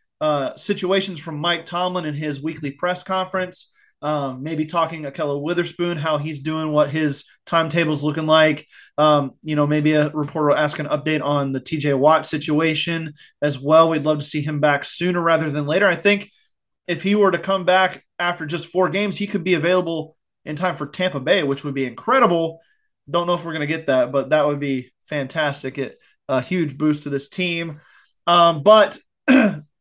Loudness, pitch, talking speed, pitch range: -20 LUFS, 160 Hz, 200 wpm, 150-175 Hz